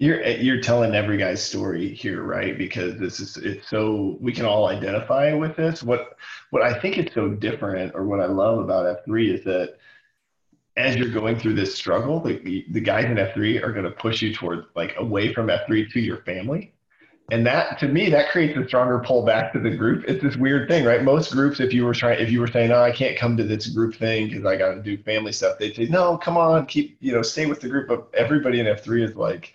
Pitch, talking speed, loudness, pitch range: 120 Hz, 240 wpm, -22 LUFS, 110-140 Hz